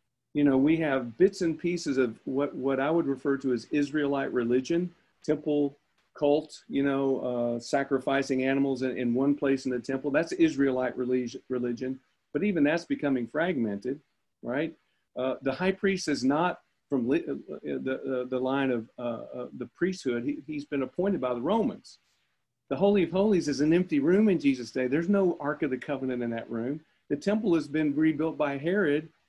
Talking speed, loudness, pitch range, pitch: 190 wpm, -28 LUFS, 130-160 Hz, 140 Hz